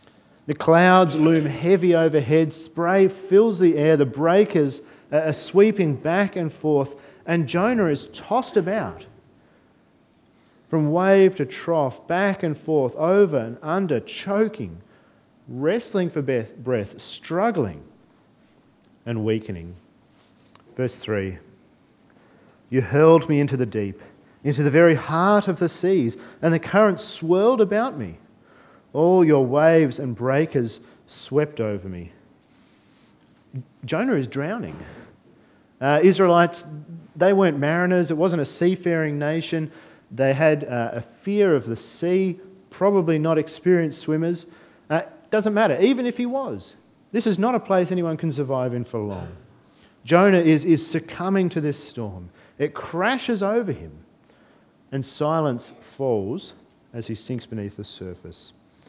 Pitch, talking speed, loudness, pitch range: 160 Hz, 135 wpm, -21 LUFS, 130-180 Hz